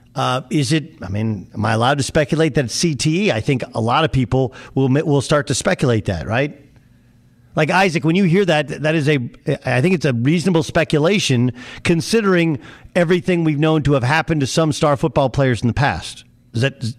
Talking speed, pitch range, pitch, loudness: 205 wpm, 125-160 Hz, 145 Hz, -17 LUFS